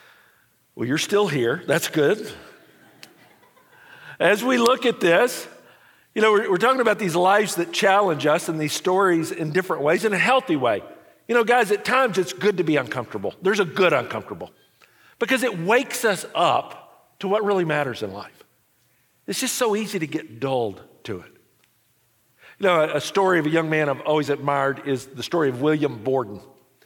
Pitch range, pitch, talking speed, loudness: 150-220 Hz, 185 Hz, 190 wpm, -21 LUFS